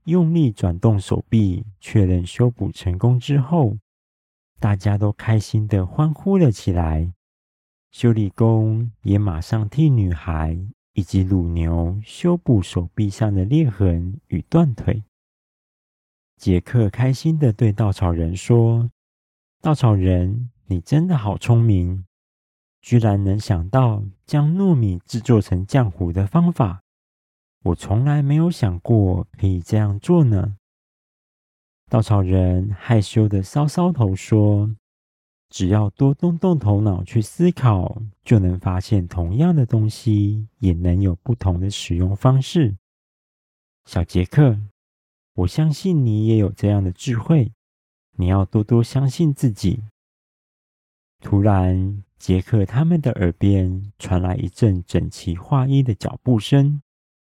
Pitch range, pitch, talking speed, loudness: 90-120 Hz, 105 Hz, 190 characters per minute, -19 LUFS